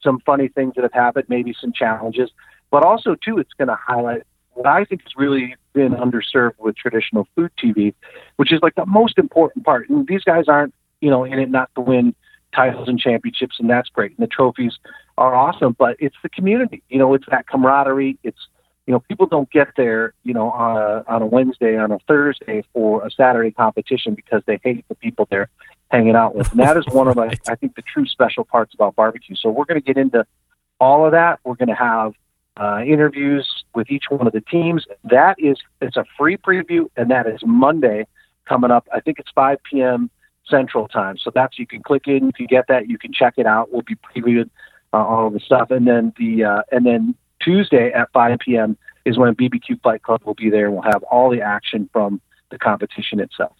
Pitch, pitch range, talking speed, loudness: 125 Hz, 115-145 Hz, 220 wpm, -17 LUFS